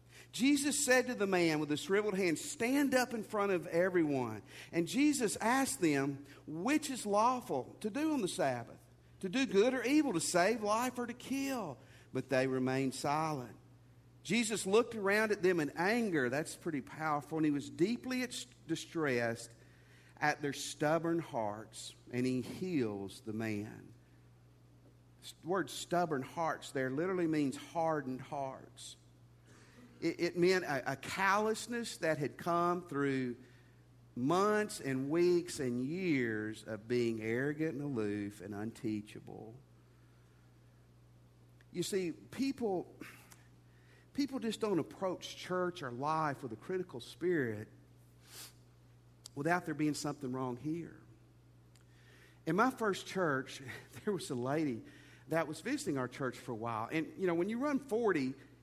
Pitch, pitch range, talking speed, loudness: 145 Hz, 120-190 Hz, 145 wpm, -35 LUFS